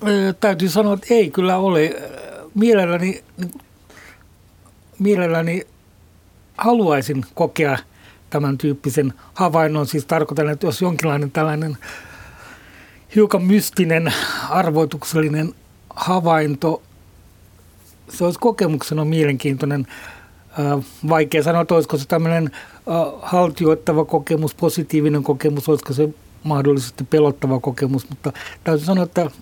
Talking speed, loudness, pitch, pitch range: 95 wpm, -19 LUFS, 155 Hz, 140-175 Hz